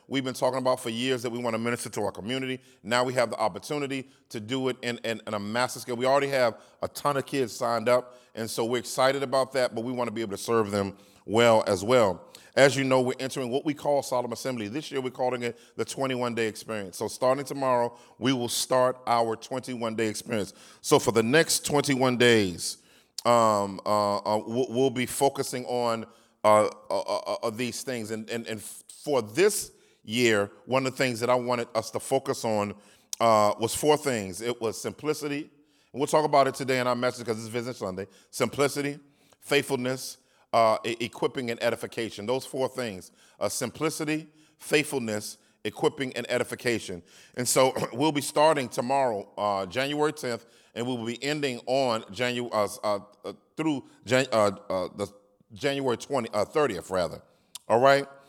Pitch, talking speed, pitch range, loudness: 125 Hz, 190 wpm, 115-135 Hz, -27 LUFS